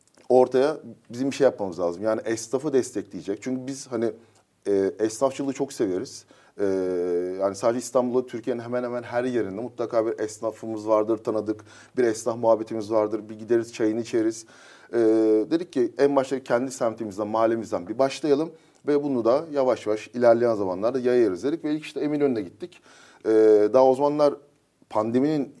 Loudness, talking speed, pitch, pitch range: -24 LUFS, 155 wpm, 115 Hz, 110-135 Hz